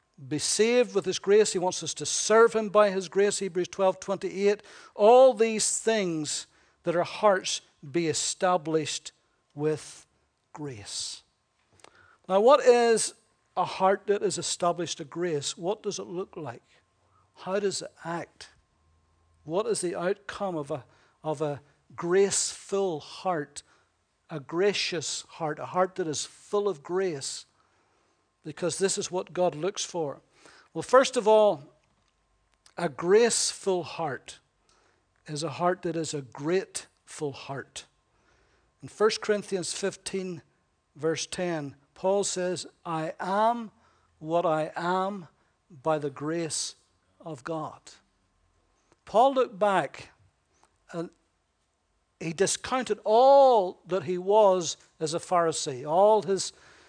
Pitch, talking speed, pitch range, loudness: 180 Hz, 130 wpm, 155-200 Hz, -27 LUFS